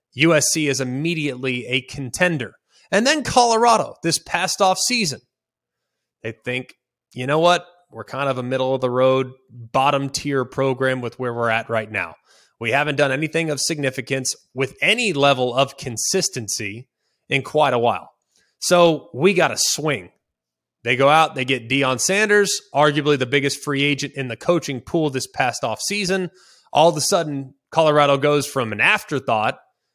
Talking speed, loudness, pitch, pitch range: 165 wpm, -19 LUFS, 140 Hz, 130-165 Hz